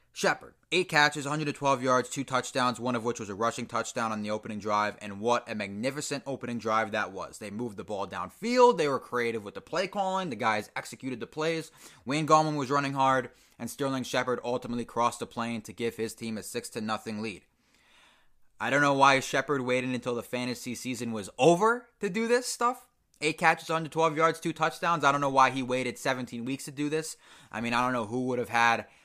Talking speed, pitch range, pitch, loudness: 220 wpm, 115-150 Hz, 125 Hz, -29 LUFS